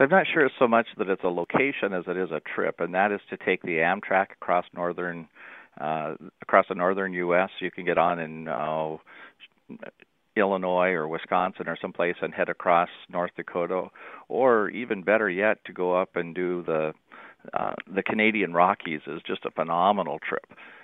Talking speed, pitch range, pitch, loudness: 180 wpm, 85-95 Hz, 90 Hz, -26 LUFS